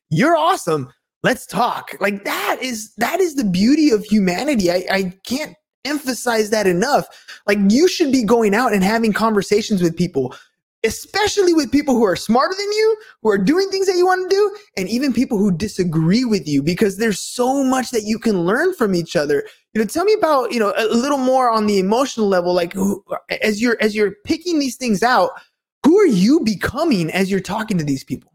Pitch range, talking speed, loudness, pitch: 200-300 Hz, 210 wpm, -18 LUFS, 225 Hz